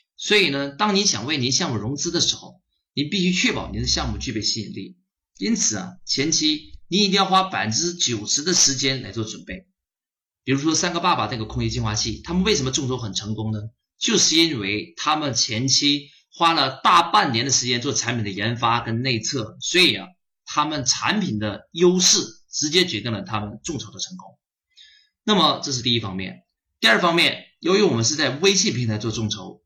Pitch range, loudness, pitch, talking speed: 115-180 Hz, -20 LUFS, 135 Hz, 300 characters per minute